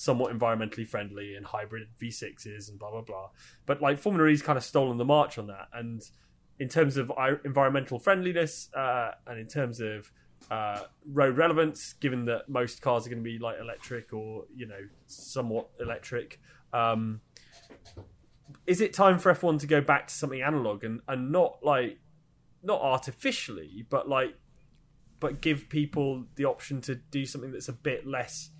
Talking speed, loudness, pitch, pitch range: 175 wpm, -29 LUFS, 130 Hz, 115-145 Hz